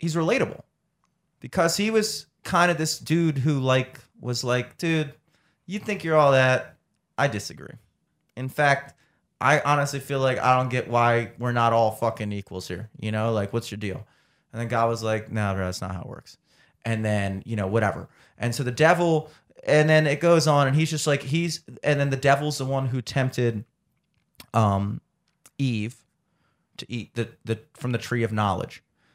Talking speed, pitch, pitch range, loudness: 190 wpm, 130 Hz, 115-155 Hz, -24 LUFS